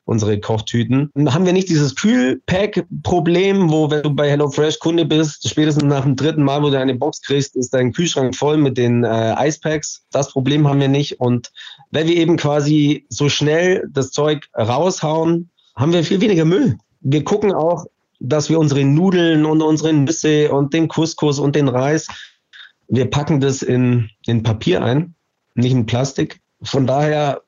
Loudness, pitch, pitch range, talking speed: -17 LUFS, 150 Hz, 135-160 Hz, 175 wpm